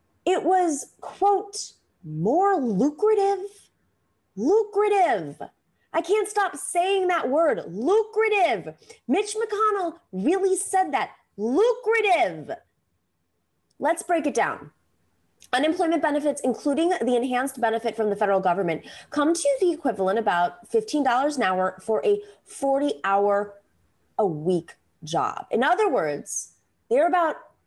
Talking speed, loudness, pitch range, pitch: 115 wpm, -24 LUFS, 235-395 Hz, 330 Hz